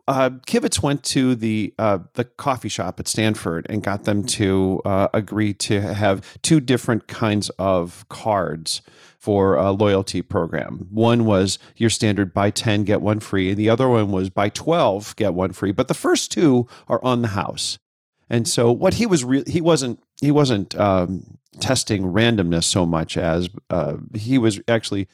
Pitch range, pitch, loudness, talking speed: 95-125 Hz, 110 Hz, -20 LUFS, 180 wpm